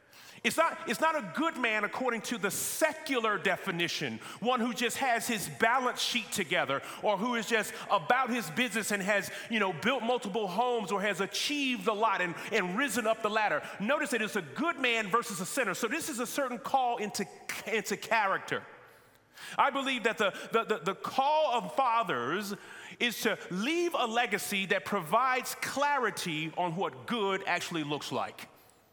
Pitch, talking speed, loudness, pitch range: 225 Hz, 180 wpm, -31 LUFS, 200-250 Hz